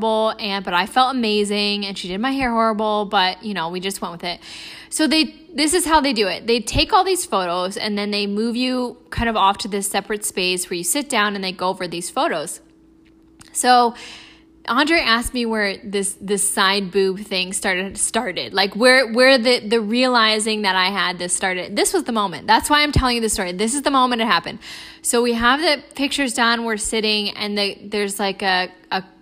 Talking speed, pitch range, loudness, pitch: 220 wpm, 195-255 Hz, -19 LUFS, 215 Hz